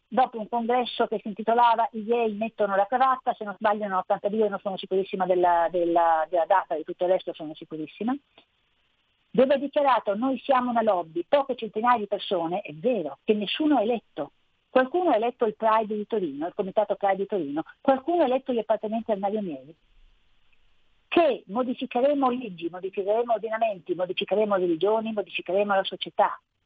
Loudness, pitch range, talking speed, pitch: -25 LUFS, 195-250 Hz, 165 wpm, 215 Hz